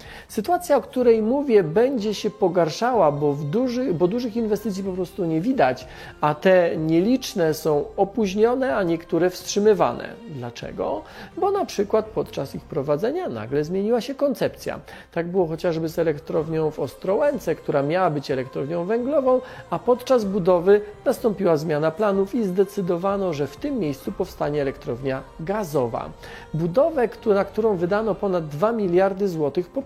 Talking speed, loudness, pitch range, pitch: 145 wpm, -22 LUFS, 165-225 Hz, 195 Hz